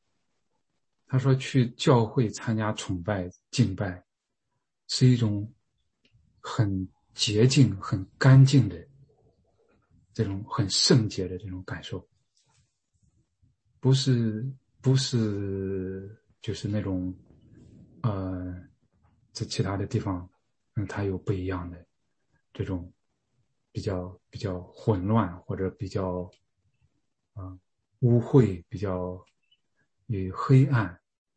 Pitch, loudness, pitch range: 105 Hz, -27 LUFS, 95-120 Hz